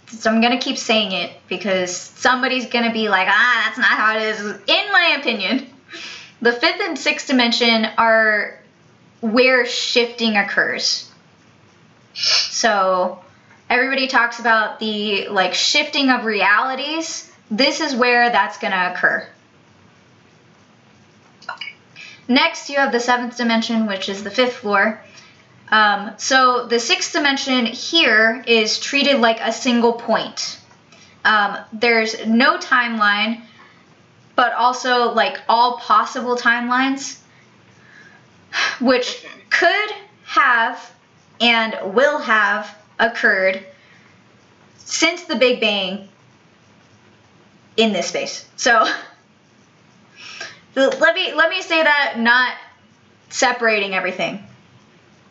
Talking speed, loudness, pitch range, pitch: 110 wpm, -17 LUFS, 215-265 Hz, 235 Hz